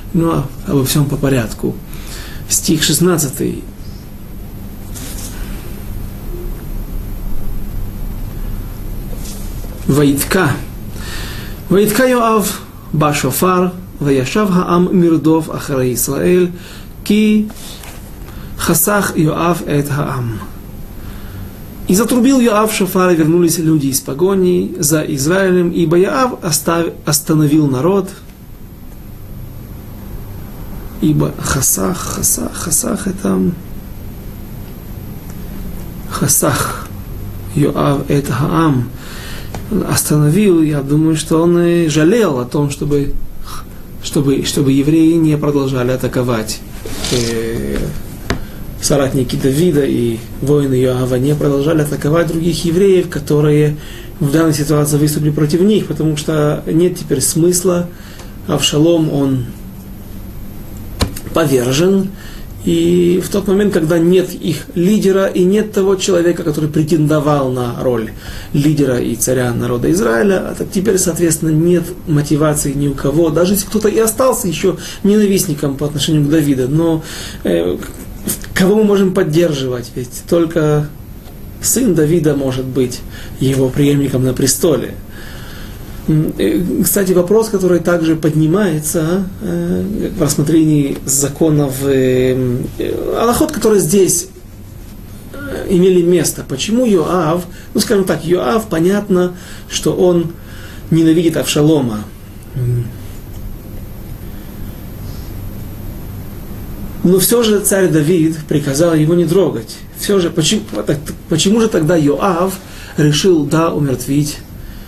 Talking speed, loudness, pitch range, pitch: 100 wpm, -14 LUFS, 110-175 Hz, 150 Hz